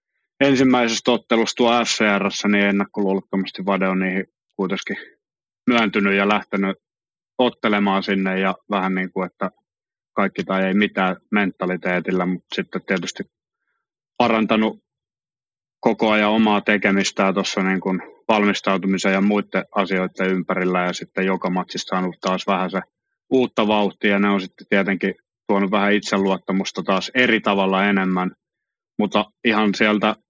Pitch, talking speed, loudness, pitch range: 100 Hz, 130 wpm, -20 LUFS, 95-105 Hz